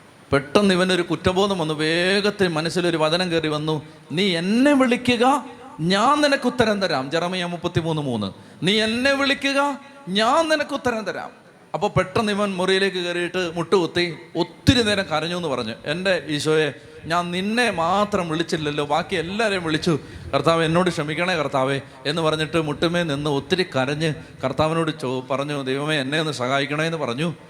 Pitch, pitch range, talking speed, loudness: 170 Hz, 155-200 Hz, 145 wpm, -21 LUFS